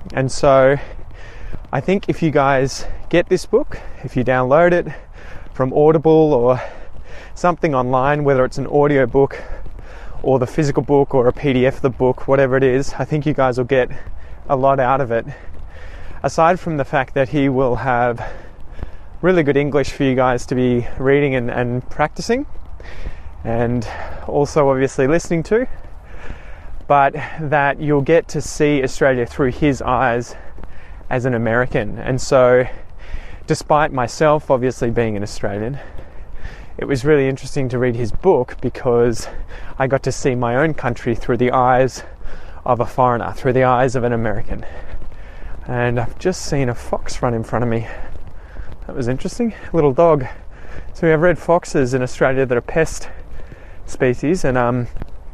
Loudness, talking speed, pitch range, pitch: -17 LUFS, 165 wpm, 115-140 Hz, 130 Hz